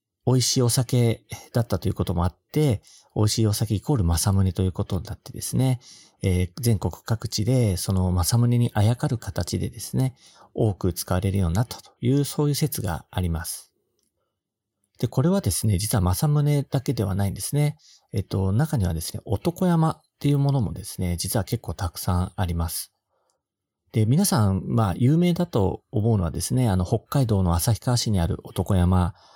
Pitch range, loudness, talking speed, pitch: 95-130 Hz, -24 LUFS, 360 characters per minute, 110 Hz